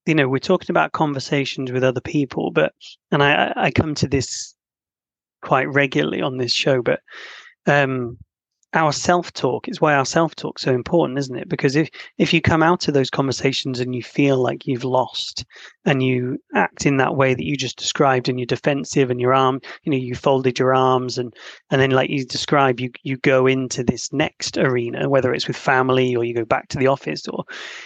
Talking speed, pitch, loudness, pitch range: 210 wpm, 135 Hz, -20 LUFS, 130-145 Hz